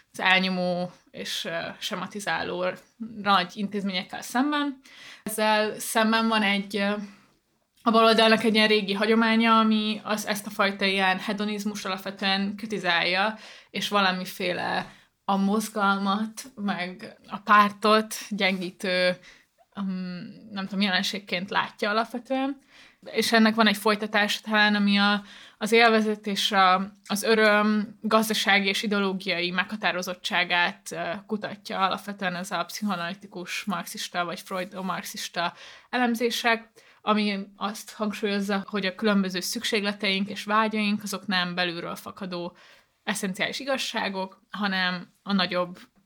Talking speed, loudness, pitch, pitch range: 110 wpm, -25 LUFS, 205 Hz, 190-220 Hz